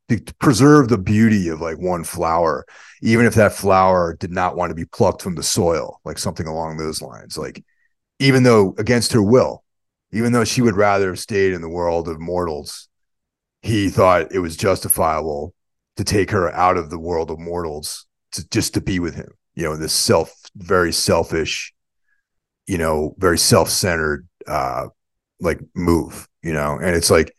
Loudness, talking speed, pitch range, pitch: -18 LUFS, 180 wpm, 85-105 Hz, 90 Hz